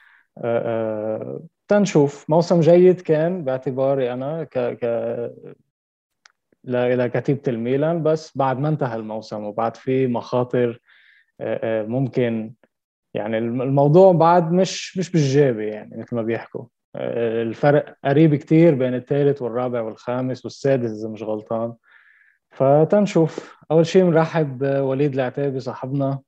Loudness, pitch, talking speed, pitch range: -20 LUFS, 135 Hz, 110 wpm, 115-155 Hz